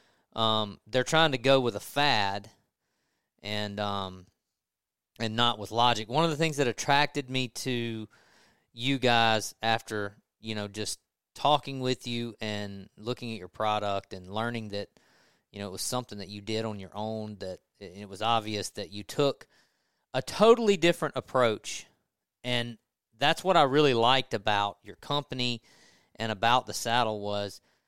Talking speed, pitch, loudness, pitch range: 160 wpm, 115 Hz, -28 LUFS, 105-130 Hz